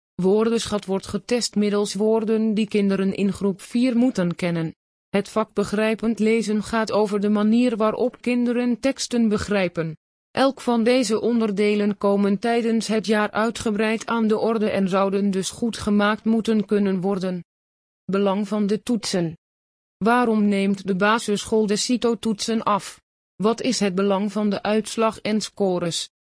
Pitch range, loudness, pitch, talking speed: 200-225 Hz, -22 LUFS, 210 Hz, 145 wpm